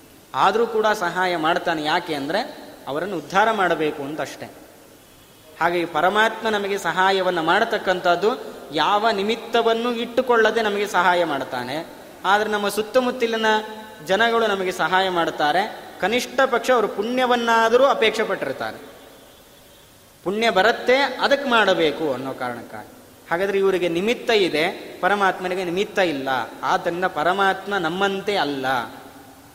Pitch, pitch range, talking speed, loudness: 195 Hz, 175-225 Hz, 105 wpm, -21 LUFS